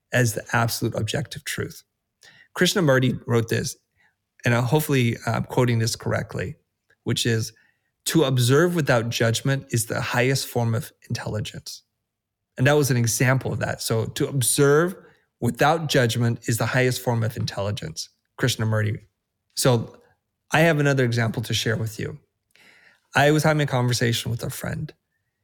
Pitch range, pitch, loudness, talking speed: 115-140 Hz, 120 Hz, -23 LUFS, 145 wpm